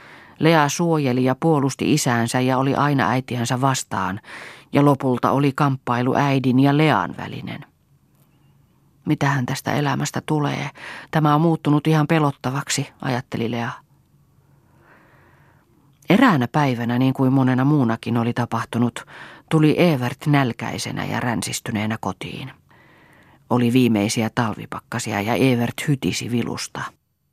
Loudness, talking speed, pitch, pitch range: -20 LUFS, 110 wpm, 130 Hz, 120-145 Hz